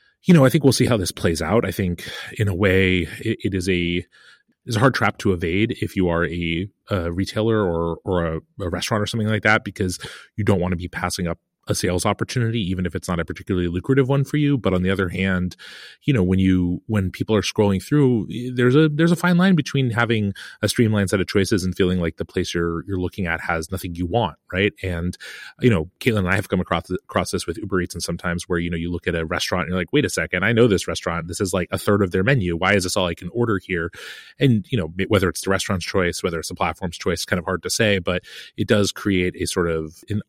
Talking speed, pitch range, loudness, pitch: 265 wpm, 90-110 Hz, -21 LUFS, 95 Hz